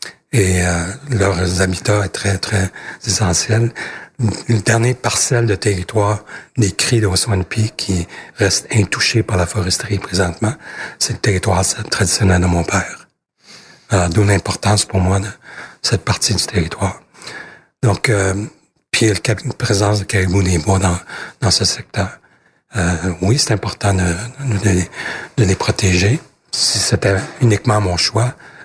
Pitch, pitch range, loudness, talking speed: 100 Hz, 95-110 Hz, -16 LUFS, 140 wpm